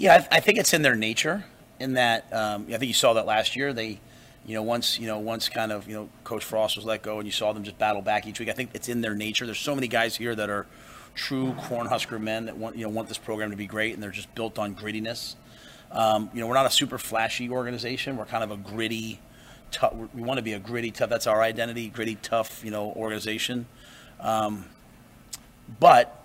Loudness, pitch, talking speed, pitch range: -26 LUFS, 110 Hz, 245 wpm, 110-120 Hz